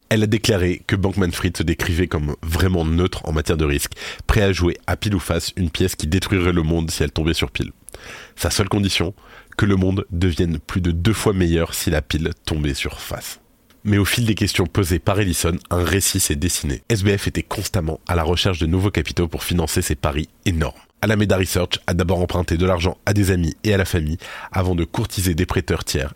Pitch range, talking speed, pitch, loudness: 85-100 Hz, 225 wpm, 90 Hz, -20 LUFS